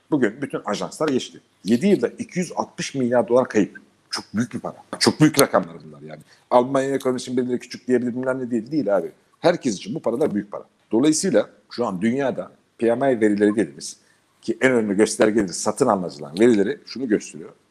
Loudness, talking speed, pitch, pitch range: -21 LUFS, 175 wpm, 125 Hz, 110-135 Hz